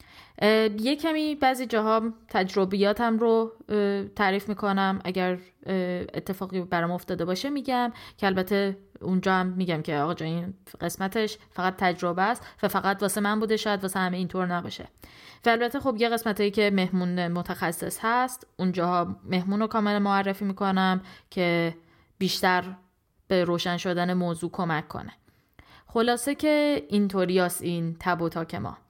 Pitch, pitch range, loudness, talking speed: 190 Hz, 180-215 Hz, -26 LUFS, 140 wpm